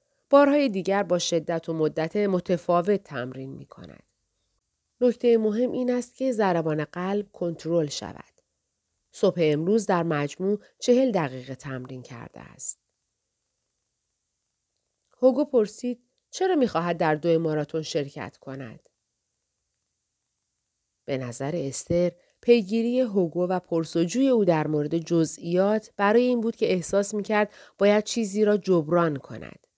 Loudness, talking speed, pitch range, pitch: -25 LUFS, 120 wpm, 160-225 Hz, 180 Hz